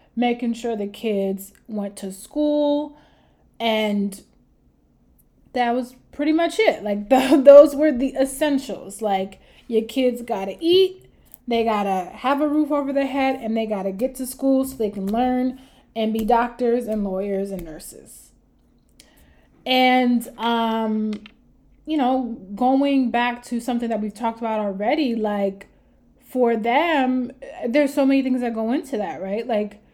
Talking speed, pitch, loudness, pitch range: 155 wpm, 240 Hz, -21 LUFS, 215-265 Hz